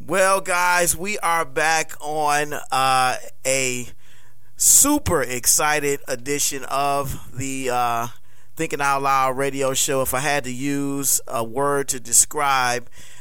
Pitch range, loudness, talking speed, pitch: 125-150 Hz, -20 LUFS, 125 wpm, 135 Hz